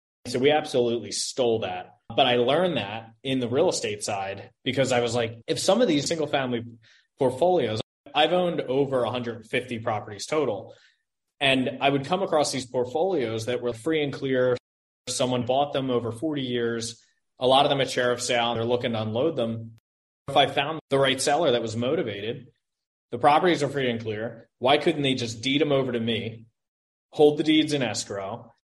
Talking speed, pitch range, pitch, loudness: 190 wpm, 115-145 Hz, 125 Hz, -25 LUFS